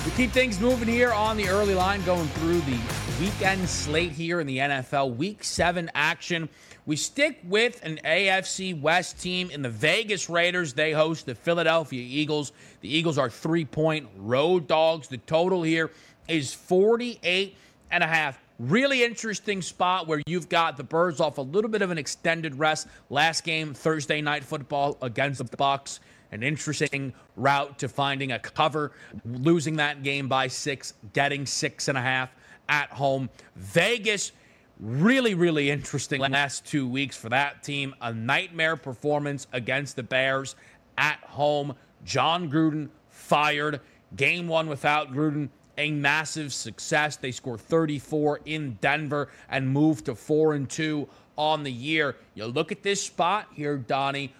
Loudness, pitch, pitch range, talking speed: -26 LUFS, 150 Hz, 135-170 Hz, 160 wpm